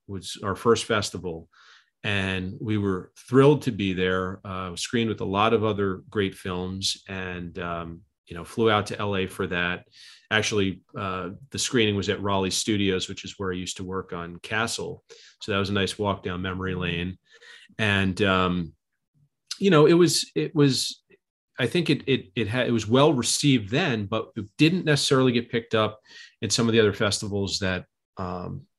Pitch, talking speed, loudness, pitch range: 100 Hz, 190 wpm, -25 LUFS, 95-115 Hz